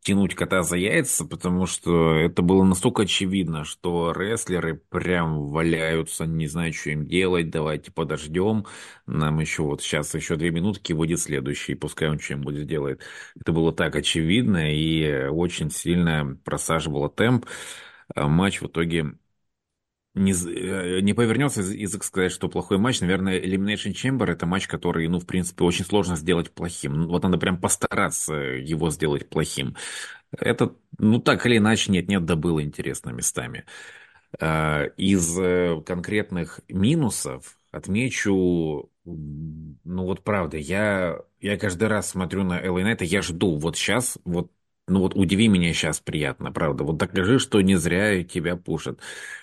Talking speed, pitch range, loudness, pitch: 145 wpm, 80-95 Hz, -24 LUFS, 90 Hz